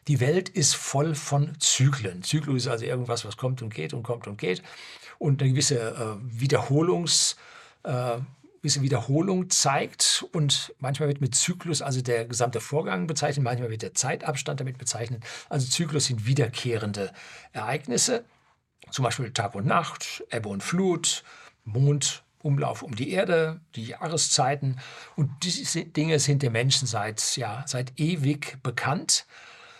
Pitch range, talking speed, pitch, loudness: 120-150 Hz, 145 wpm, 135 Hz, -26 LUFS